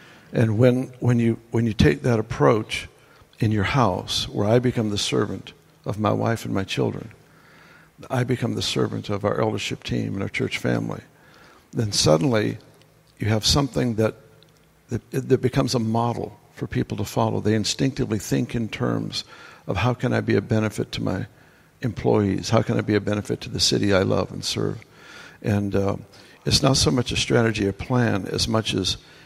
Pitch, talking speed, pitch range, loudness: 115 Hz, 190 wpm, 105-125 Hz, -23 LUFS